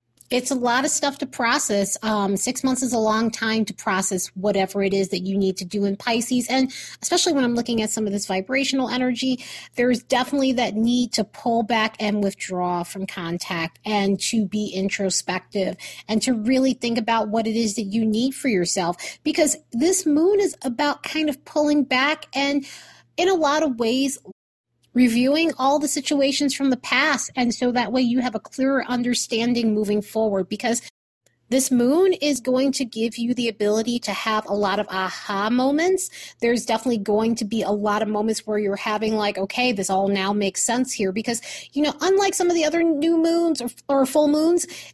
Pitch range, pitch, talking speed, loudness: 210-270 Hz, 235 Hz, 200 wpm, -22 LUFS